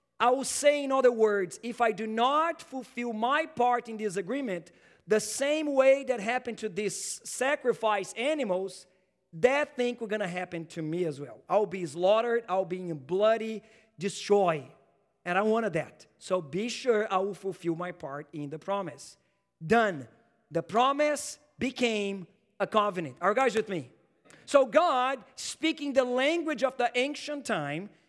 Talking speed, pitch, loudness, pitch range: 170 wpm, 215 Hz, -29 LUFS, 185-255 Hz